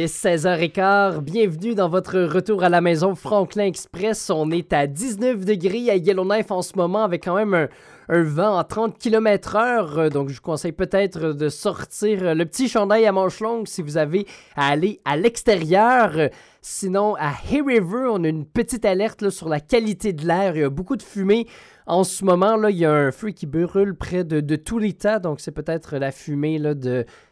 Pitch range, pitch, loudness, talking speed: 165-210 Hz, 190 Hz, -21 LUFS, 205 wpm